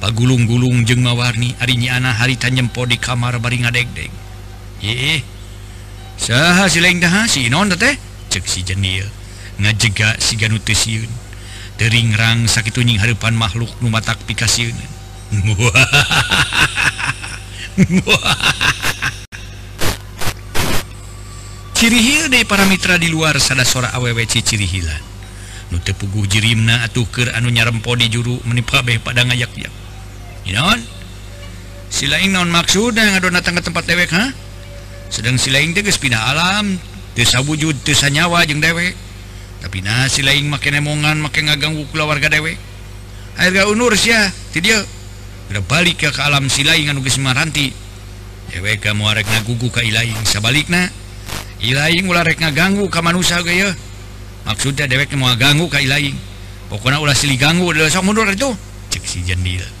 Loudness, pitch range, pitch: -14 LUFS, 100-150 Hz, 120 Hz